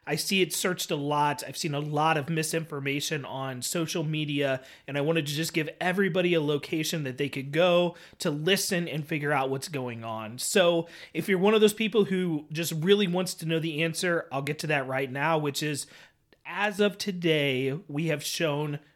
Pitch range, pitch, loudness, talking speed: 145-175 Hz, 160 Hz, -27 LUFS, 205 wpm